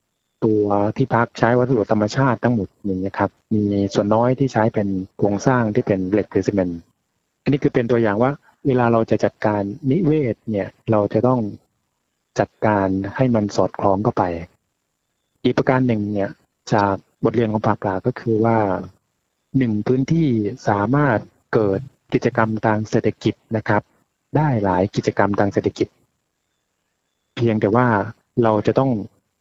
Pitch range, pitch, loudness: 100-125 Hz, 110 Hz, -20 LUFS